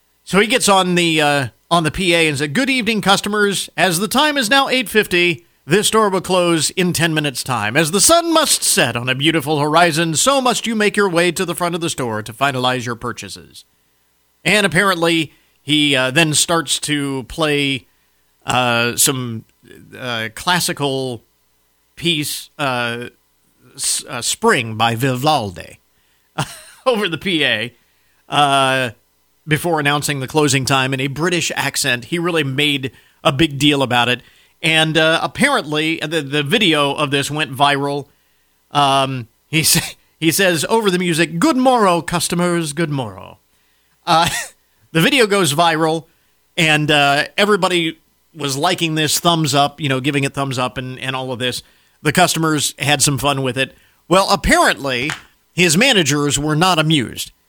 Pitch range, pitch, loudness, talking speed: 130-175 Hz, 150 Hz, -16 LUFS, 160 wpm